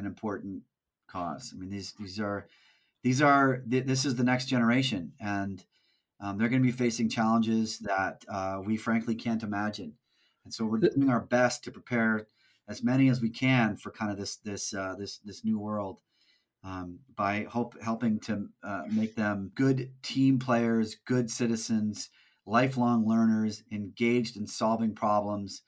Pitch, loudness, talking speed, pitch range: 110 Hz, -29 LUFS, 165 wpm, 105-120 Hz